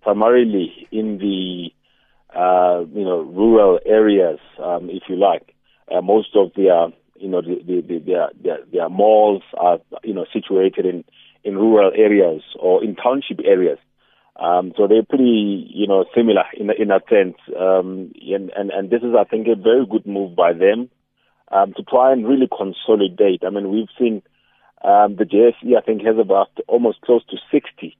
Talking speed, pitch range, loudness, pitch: 175 wpm, 95-115 Hz, -17 LUFS, 105 Hz